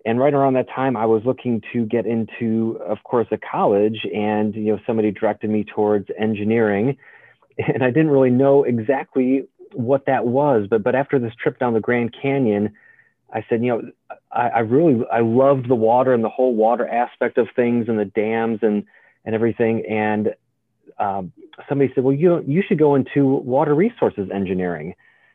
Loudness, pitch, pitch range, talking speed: -19 LUFS, 120 Hz, 110-135 Hz, 185 wpm